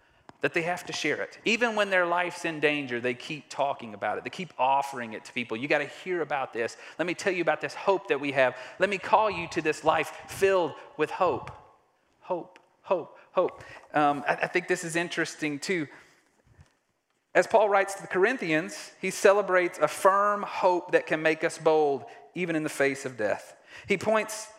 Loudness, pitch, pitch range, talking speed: -27 LUFS, 165 Hz, 150-190 Hz, 205 wpm